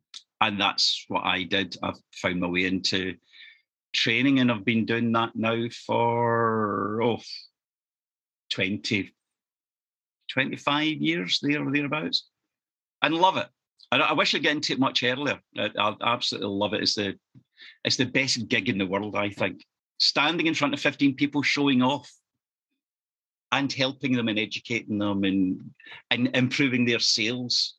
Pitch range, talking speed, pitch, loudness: 105-135 Hz, 155 wpm, 115 Hz, -25 LUFS